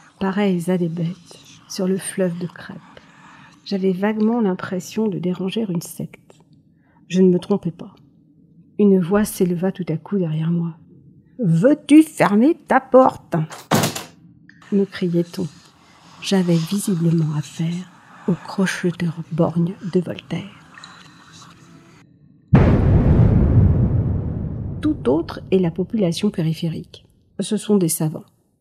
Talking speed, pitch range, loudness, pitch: 110 wpm, 165-195 Hz, -19 LUFS, 180 Hz